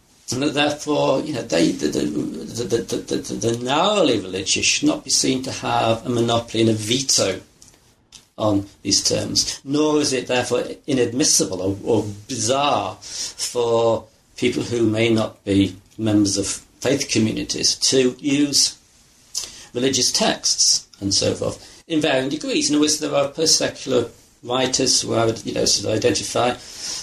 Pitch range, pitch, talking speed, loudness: 110-135 Hz, 120 Hz, 160 wpm, -20 LUFS